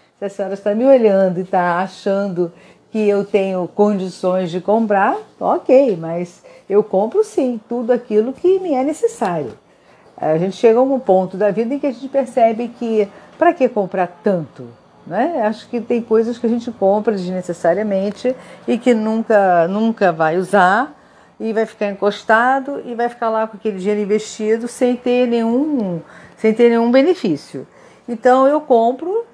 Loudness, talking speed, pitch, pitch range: -17 LUFS, 165 wpm, 220 Hz, 195-245 Hz